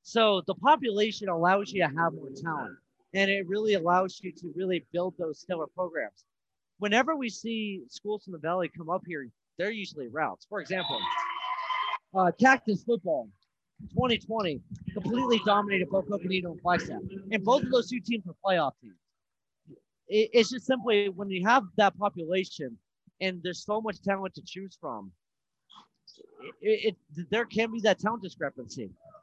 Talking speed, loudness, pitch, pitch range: 160 wpm, -29 LUFS, 195 Hz, 180-225 Hz